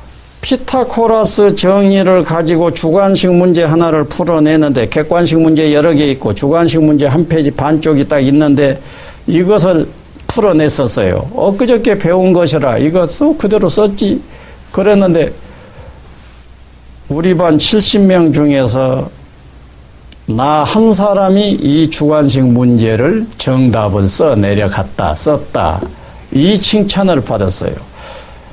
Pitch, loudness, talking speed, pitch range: 155 Hz, -11 LUFS, 245 characters per minute, 130-190 Hz